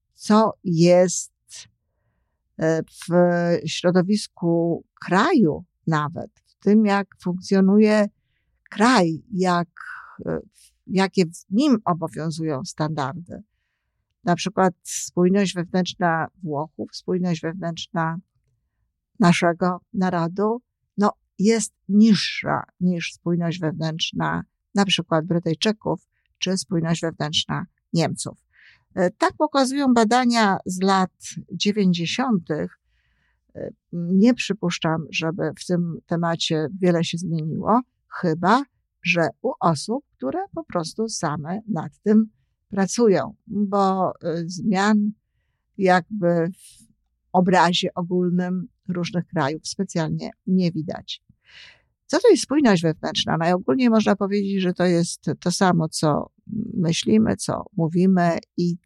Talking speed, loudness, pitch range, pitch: 95 wpm, -22 LUFS, 165-205 Hz, 180 Hz